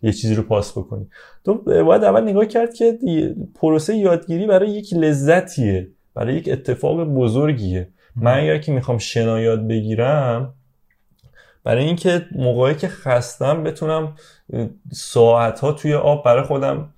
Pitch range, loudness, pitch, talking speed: 115-165 Hz, -18 LUFS, 140 Hz, 140 wpm